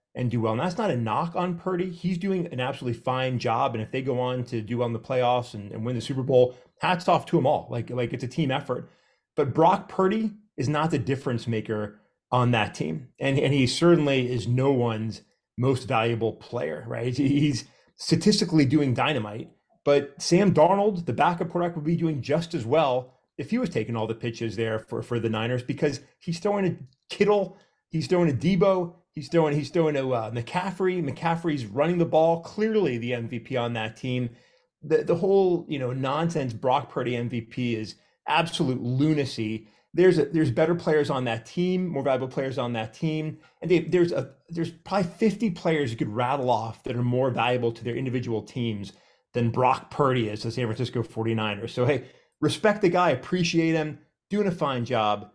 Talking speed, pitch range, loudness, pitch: 200 wpm, 120-165 Hz, -26 LUFS, 135 Hz